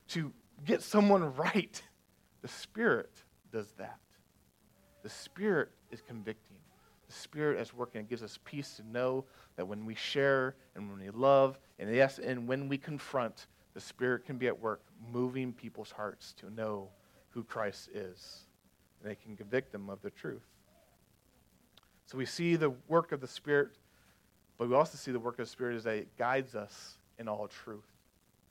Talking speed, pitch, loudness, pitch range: 175 wpm, 125 Hz, -35 LUFS, 110-140 Hz